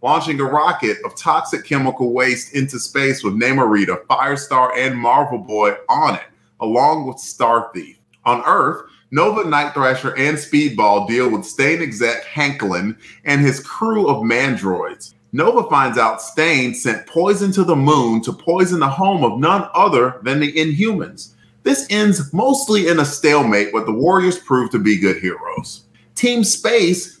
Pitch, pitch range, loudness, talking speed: 145 Hz, 125-175 Hz, -16 LUFS, 160 wpm